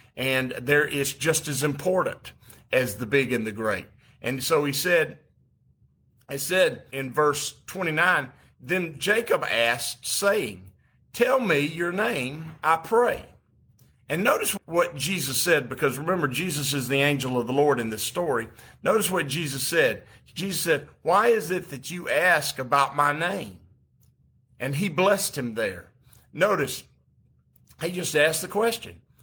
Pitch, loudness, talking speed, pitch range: 145 Hz, -25 LUFS, 150 wpm, 130-180 Hz